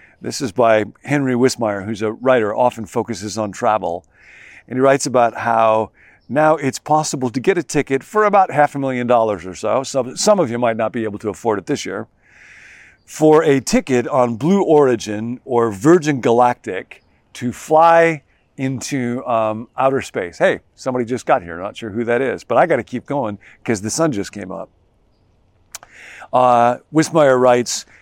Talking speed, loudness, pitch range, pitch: 180 wpm, -17 LUFS, 110-140 Hz, 125 Hz